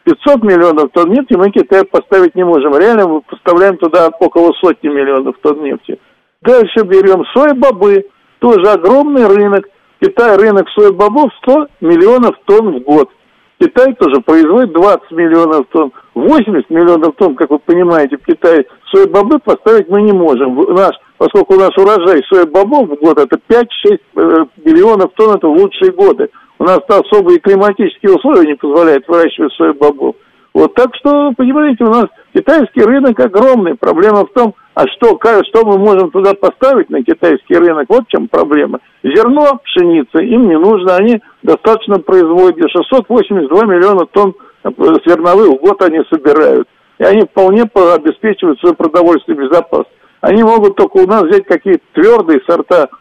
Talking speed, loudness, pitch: 160 wpm, -8 LUFS, 225 Hz